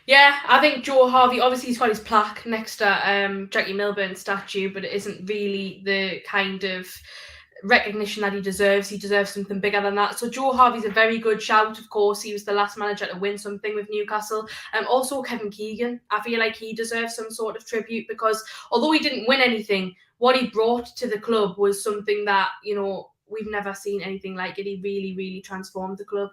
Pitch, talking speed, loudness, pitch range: 210 Hz, 215 wpm, -22 LUFS, 200-225 Hz